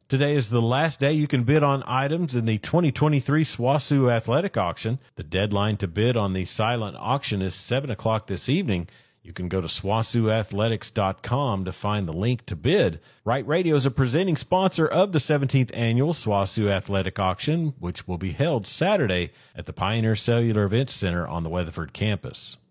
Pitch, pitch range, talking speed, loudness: 115 Hz, 95-140 Hz, 180 wpm, -24 LUFS